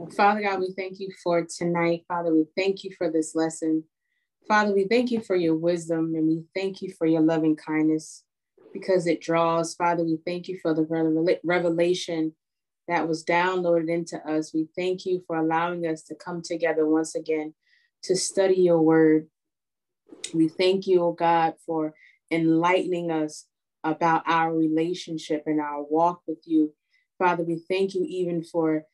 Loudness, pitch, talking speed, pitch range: -25 LUFS, 170 Hz, 170 wpm, 160-180 Hz